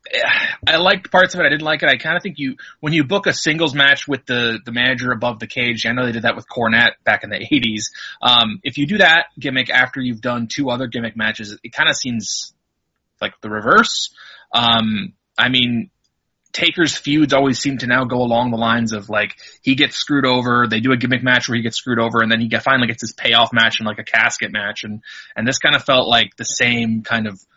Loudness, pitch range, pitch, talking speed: -16 LUFS, 115-135 Hz, 120 Hz, 240 wpm